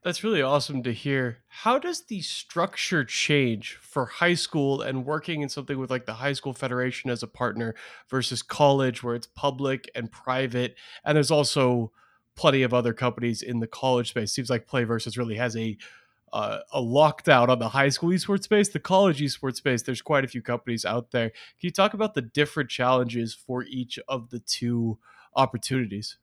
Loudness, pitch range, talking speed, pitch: -26 LUFS, 120-145 Hz, 195 wpm, 130 Hz